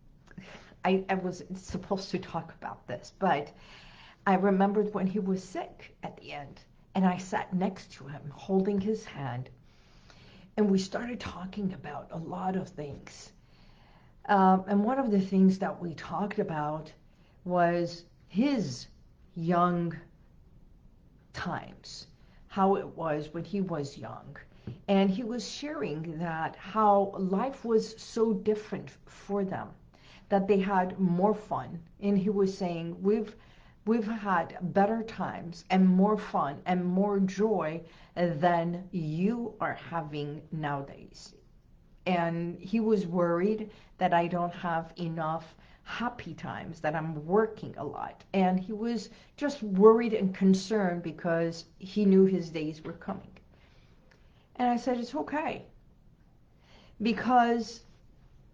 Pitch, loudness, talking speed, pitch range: 190 Hz, -30 LUFS, 135 wpm, 165-210 Hz